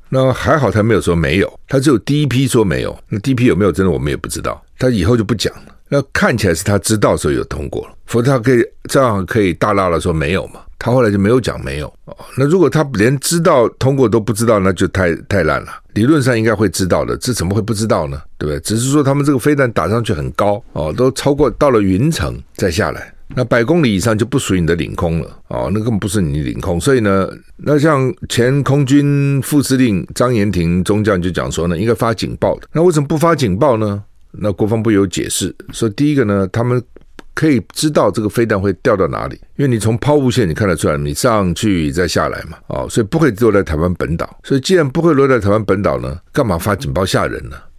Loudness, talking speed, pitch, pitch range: -15 LUFS, 355 characters per minute, 115 Hz, 95-135 Hz